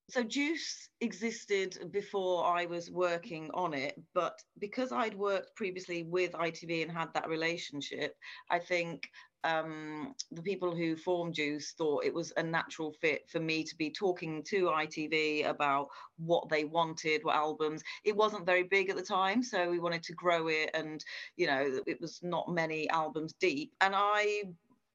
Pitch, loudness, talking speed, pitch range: 170 Hz, -34 LUFS, 170 wpm, 160-195 Hz